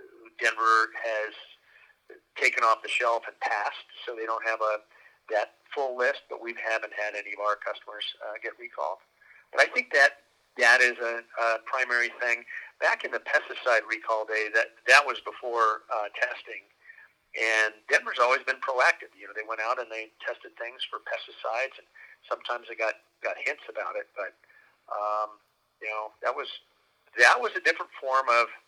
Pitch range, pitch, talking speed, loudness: 110-115 Hz, 110 Hz, 180 wpm, -27 LUFS